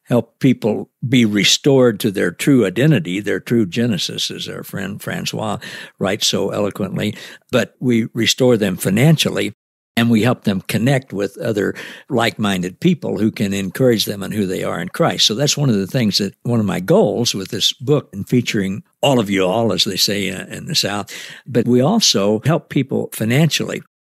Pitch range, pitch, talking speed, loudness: 105-135 Hz, 120 Hz, 185 wpm, -17 LUFS